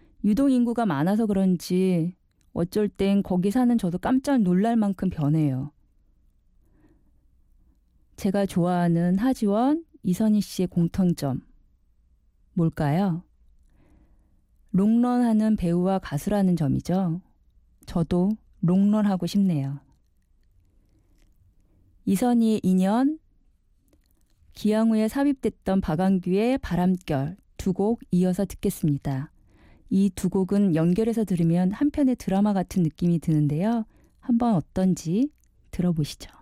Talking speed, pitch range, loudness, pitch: 230 characters per minute, 165-215 Hz, -24 LUFS, 185 Hz